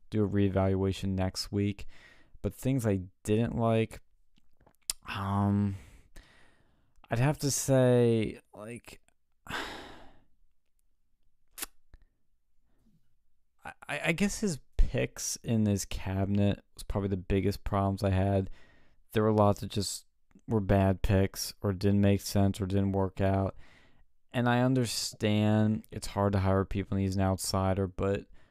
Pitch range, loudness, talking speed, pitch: 95-110 Hz, -30 LUFS, 125 wpm, 100 Hz